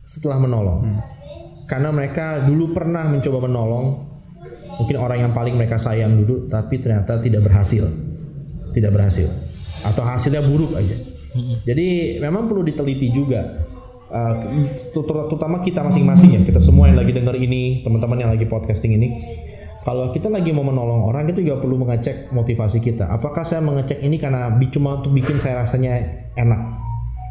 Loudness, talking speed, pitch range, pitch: -18 LUFS, 150 wpm, 110-145 Hz, 125 Hz